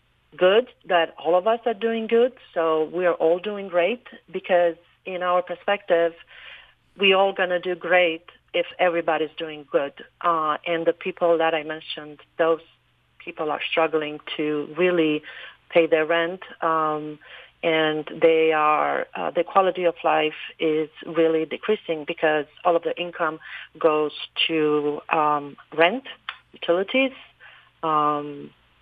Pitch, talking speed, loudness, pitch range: 165 Hz, 140 wpm, -23 LUFS, 155-180 Hz